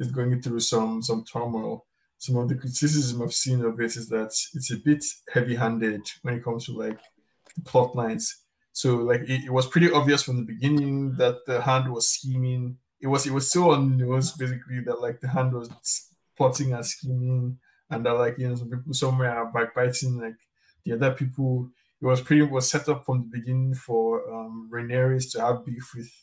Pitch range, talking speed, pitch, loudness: 120-135 Hz, 210 wpm, 125 Hz, -25 LUFS